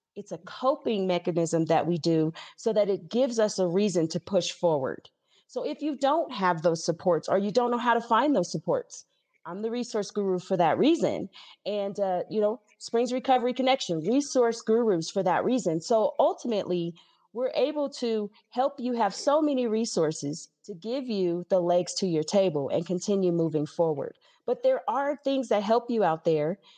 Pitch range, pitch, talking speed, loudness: 175-250 Hz, 205 Hz, 190 wpm, -27 LUFS